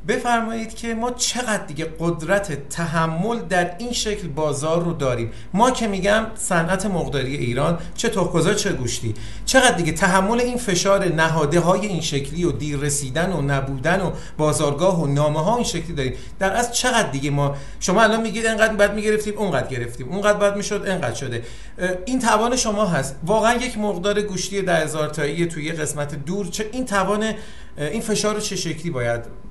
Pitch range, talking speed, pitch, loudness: 150-215 Hz, 170 wpm, 180 Hz, -21 LUFS